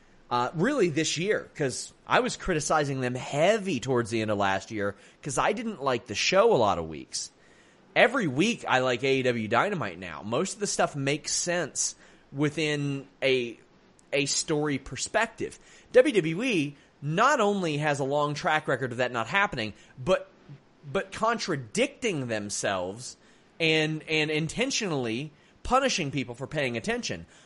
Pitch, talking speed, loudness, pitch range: 150 Hz, 150 wpm, -27 LUFS, 130-180 Hz